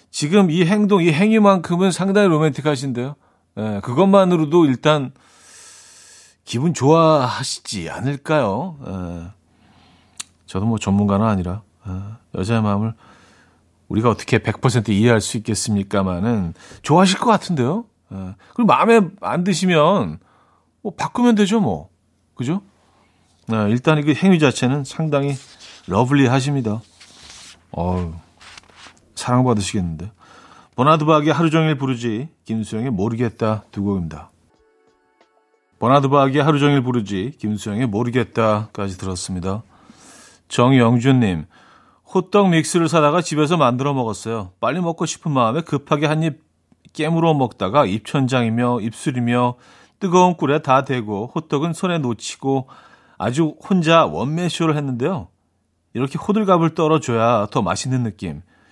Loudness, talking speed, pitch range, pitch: -18 LUFS, 285 characters per minute, 105-160 Hz, 130 Hz